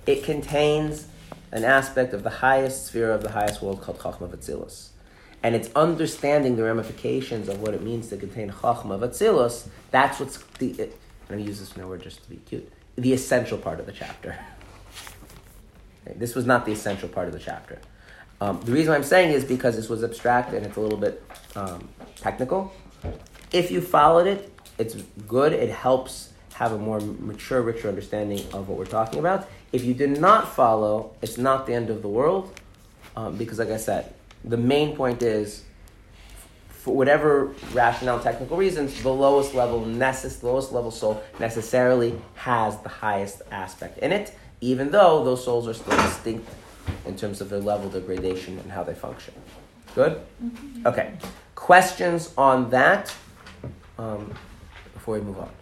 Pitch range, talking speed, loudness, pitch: 100-130 Hz, 175 wpm, -24 LUFS, 115 Hz